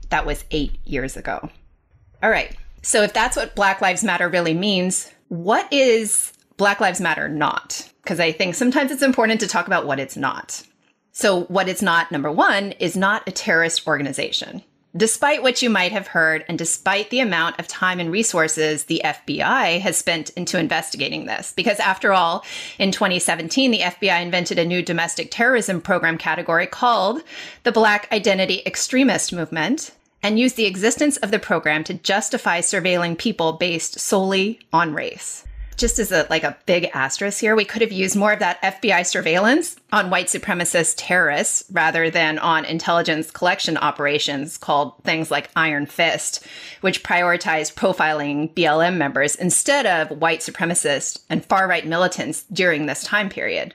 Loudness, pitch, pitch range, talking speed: -19 LUFS, 180 Hz, 165-210 Hz, 165 wpm